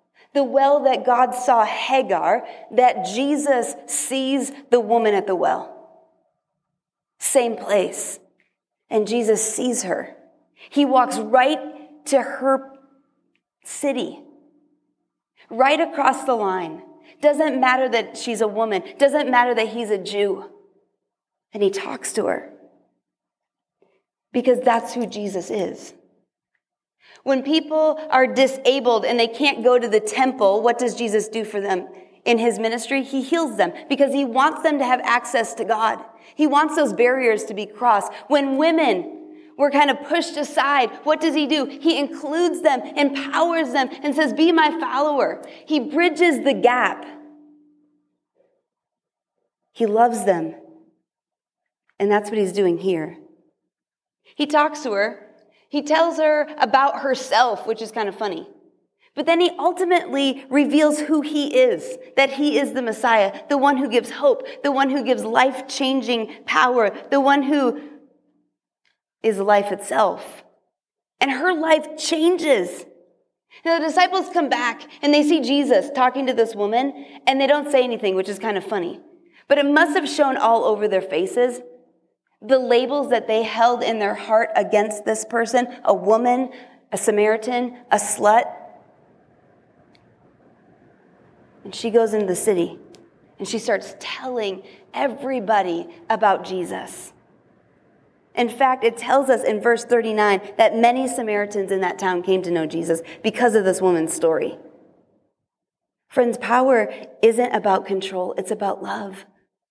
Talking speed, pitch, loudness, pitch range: 145 wpm, 260 Hz, -20 LUFS, 225-295 Hz